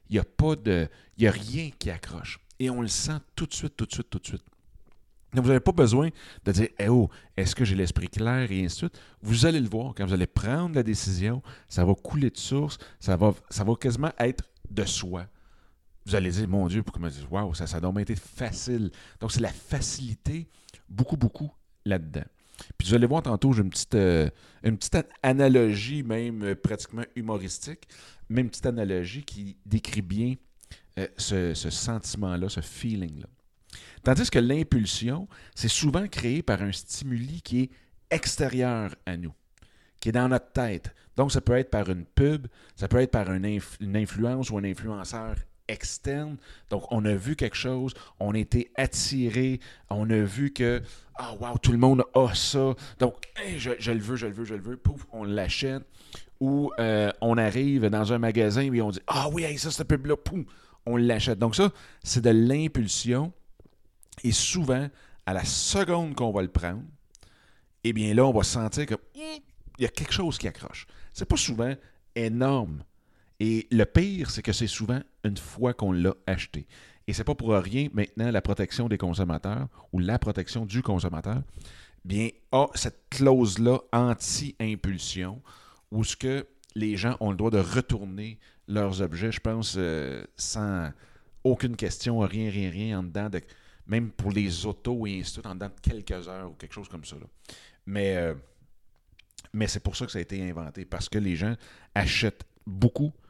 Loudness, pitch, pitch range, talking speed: -27 LUFS, 110 Hz, 95-125 Hz, 190 wpm